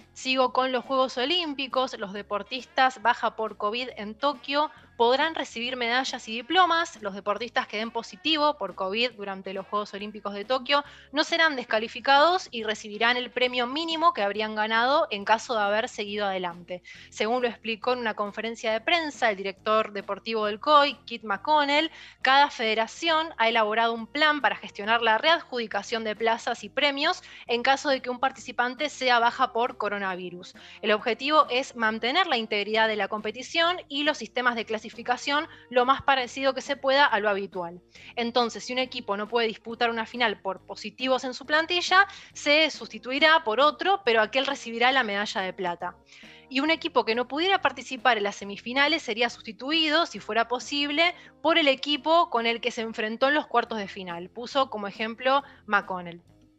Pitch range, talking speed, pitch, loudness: 215-275 Hz, 175 wpm, 240 Hz, -25 LUFS